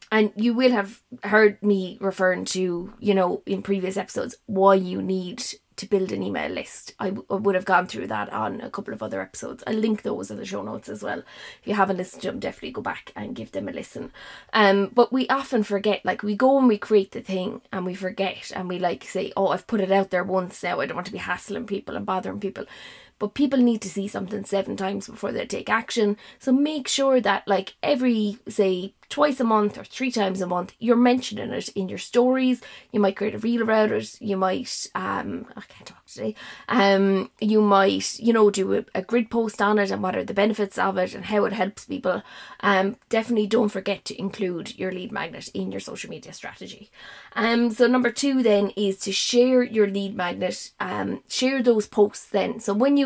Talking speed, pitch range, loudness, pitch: 225 wpm, 195-230 Hz, -24 LUFS, 205 Hz